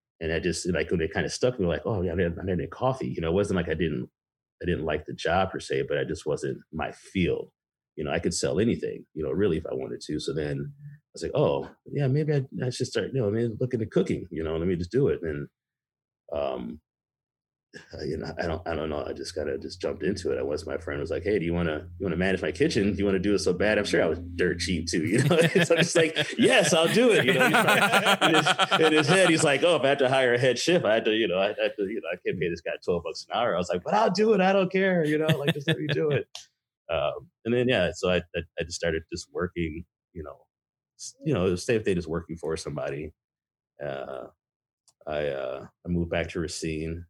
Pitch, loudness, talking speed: 135 Hz, -26 LUFS, 285 wpm